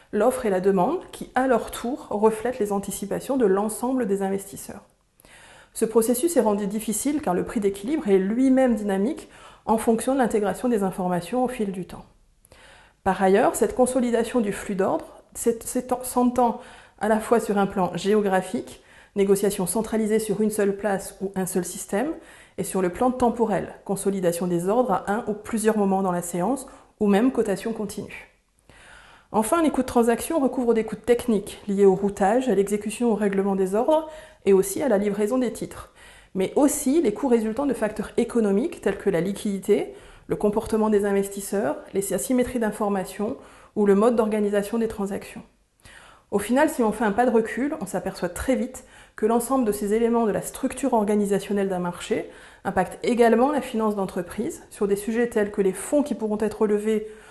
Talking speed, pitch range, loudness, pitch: 180 wpm, 195-245 Hz, -24 LUFS, 215 Hz